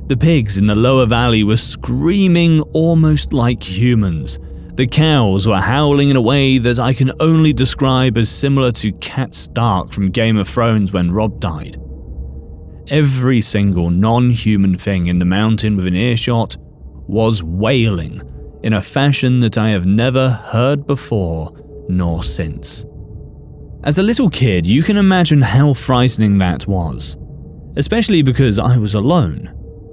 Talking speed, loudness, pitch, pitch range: 150 wpm, -14 LUFS, 115 Hz, 95-135 Hz